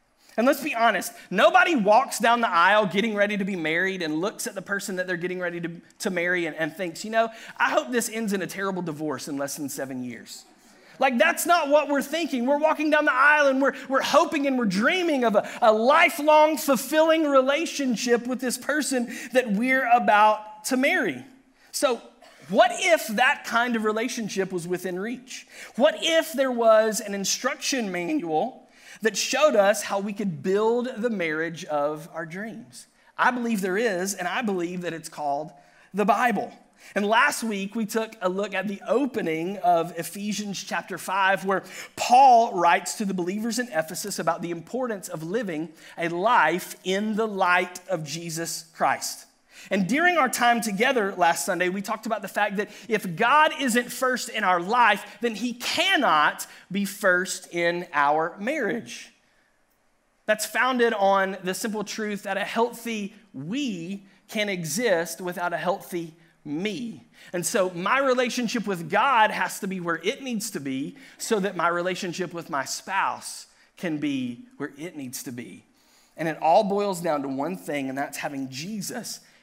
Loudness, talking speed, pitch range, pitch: -24 LUFS, 180 wpm, 180-250 Hz, 210 Hz